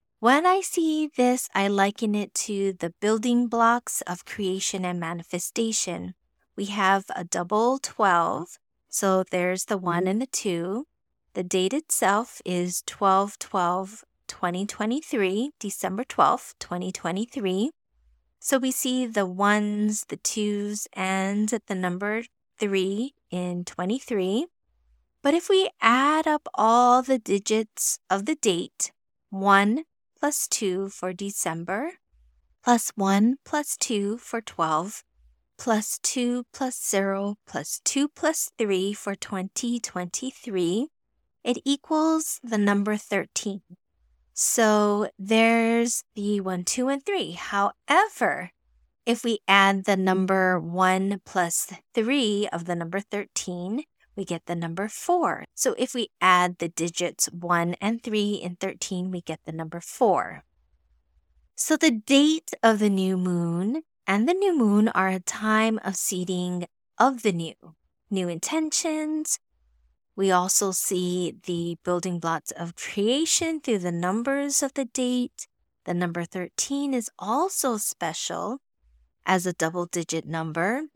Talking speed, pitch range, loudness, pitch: 130 wpm, 180-245 Hz, -25 LUFS, 200 Hz